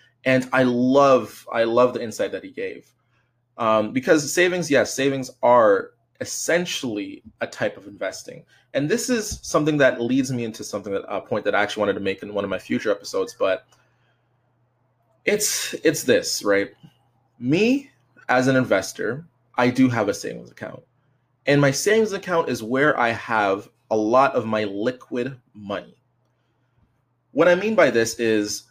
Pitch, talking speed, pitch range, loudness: 125 Hz, 170 wpm, 115-140 Hz, -21 LUFS